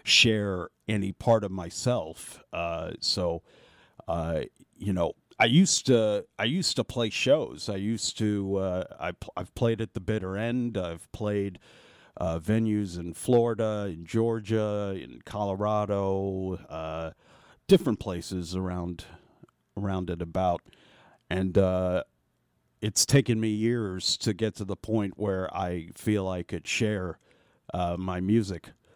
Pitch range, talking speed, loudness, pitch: 90-110 Hz, 140 wpm, -28 LUFS, 100 Hz